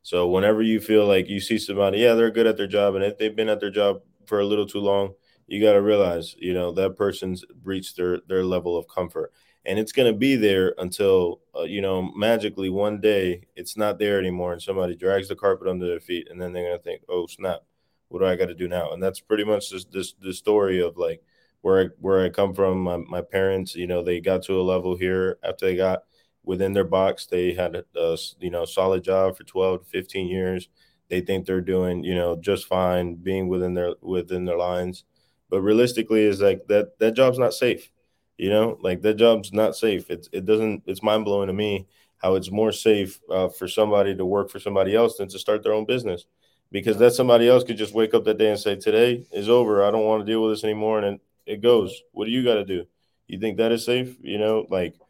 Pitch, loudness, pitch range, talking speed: 100 Hz, -23 LUFS, 95-110 Hz, 240 wpm